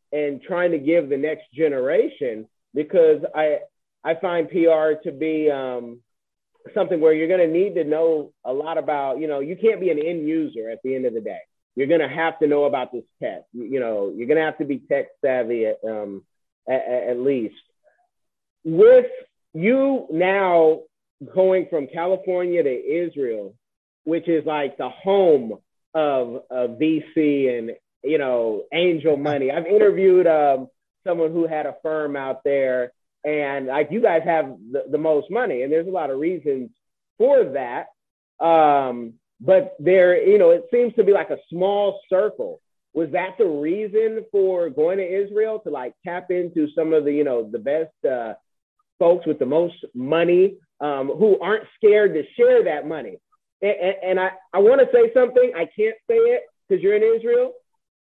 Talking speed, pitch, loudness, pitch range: 180 wpm, 170 Hz, -20 LUFS, 150-240 Hz